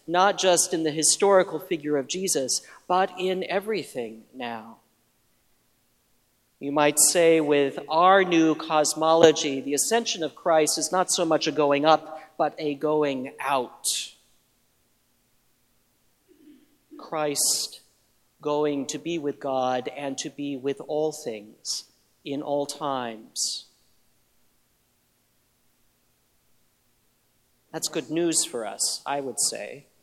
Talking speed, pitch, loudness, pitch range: 115 wpm, 155 Hz, -24 LUFS, 140-170 Hz